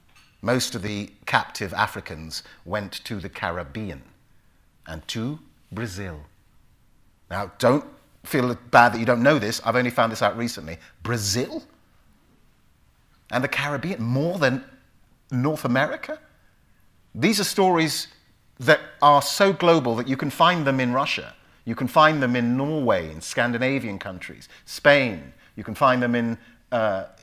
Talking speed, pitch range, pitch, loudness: 145 wpm, 100-140 Hz, 120 Hz, -22 LUFS